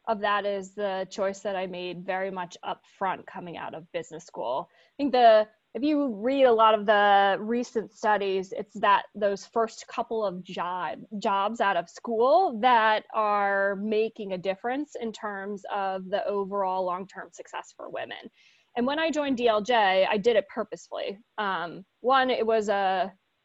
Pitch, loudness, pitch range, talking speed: 210 Hz, -26 LUFS, 195-235 Hz, 175 wpm